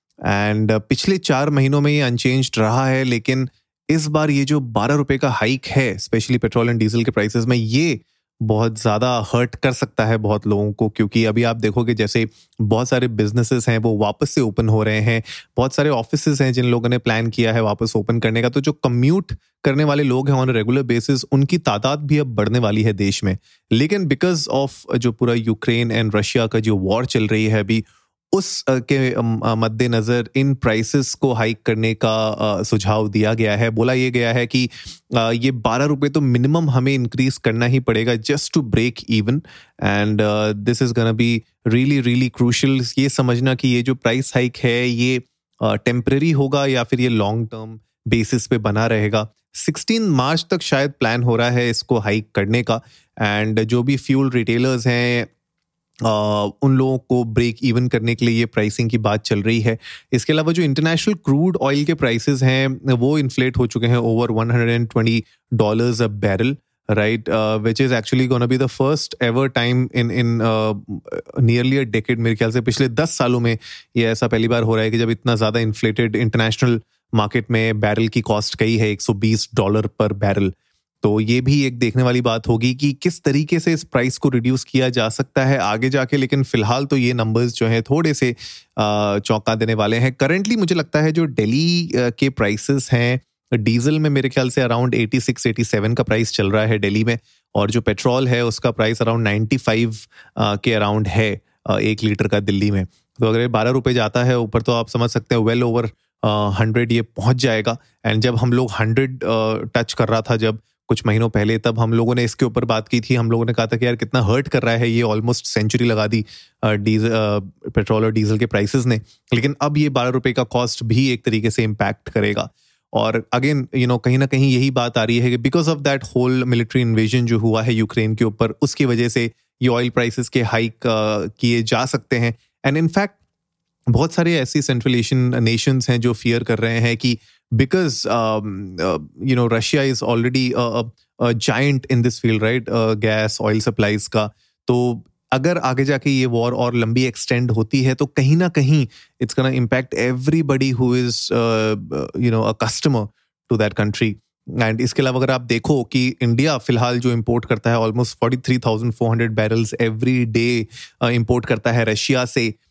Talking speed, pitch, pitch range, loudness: 195 wpm, 120 Hz, 110-130 Hz, -18 LUFS